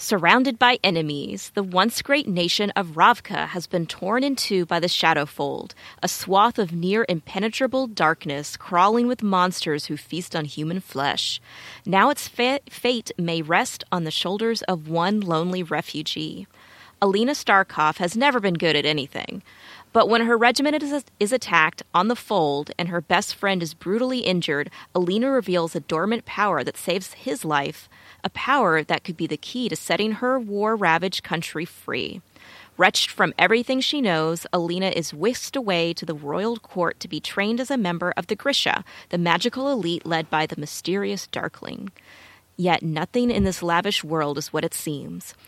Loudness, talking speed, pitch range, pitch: -22 LUFS, 175 wpm, 165-230 Hz, 180 Hz